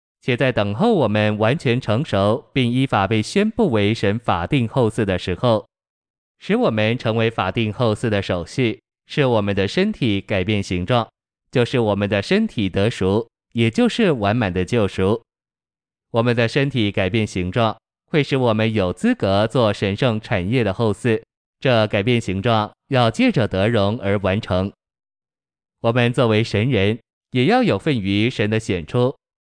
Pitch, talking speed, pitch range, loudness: 110 Hz, 235 characters per minute, 100-125 Hz, -19 LUFS